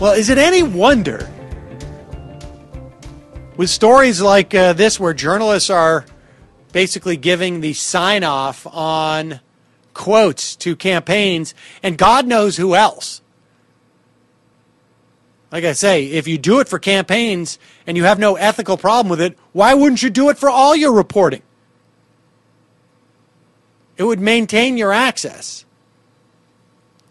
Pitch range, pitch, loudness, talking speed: 165-215 Hz, 190 Hz, -14 LUFS, 130 wpm